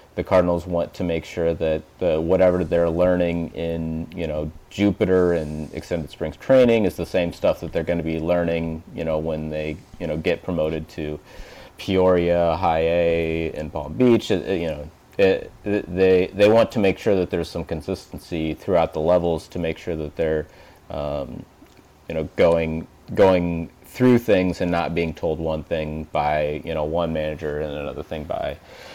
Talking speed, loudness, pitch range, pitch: 185 wpm, -22 LUFS, 80-90 Hz, 85 Hz